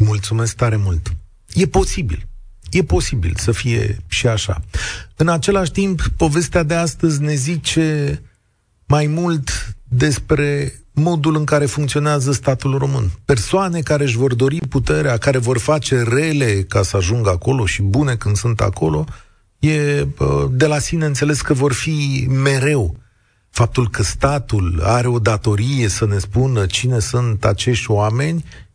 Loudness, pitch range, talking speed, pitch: -17 LUFS, 105-150 Hz, 145 wpm, 125 Hz